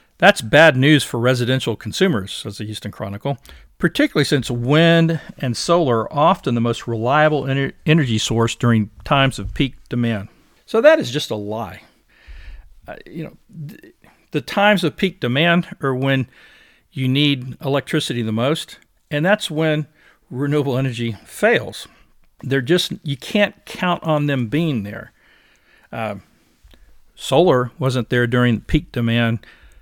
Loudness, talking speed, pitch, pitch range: -18 LUFS, 145 wpm, 135 Hz, 115-160 Hz